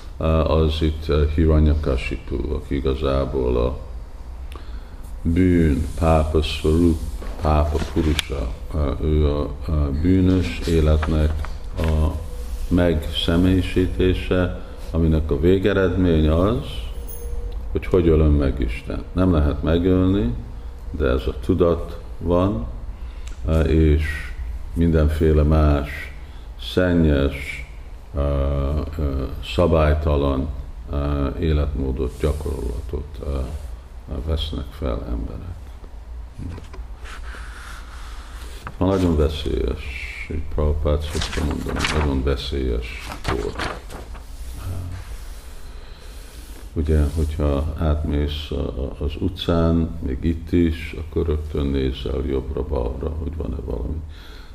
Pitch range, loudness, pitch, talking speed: 70-80 Hz, -22 LUFS, 75 Hz, 85 wpm